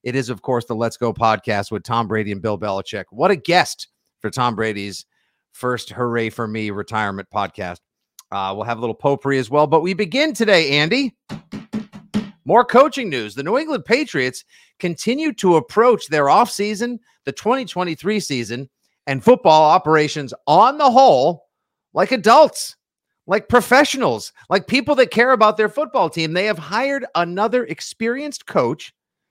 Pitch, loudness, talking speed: 170 Hz, -18 LUFS, 160 wpm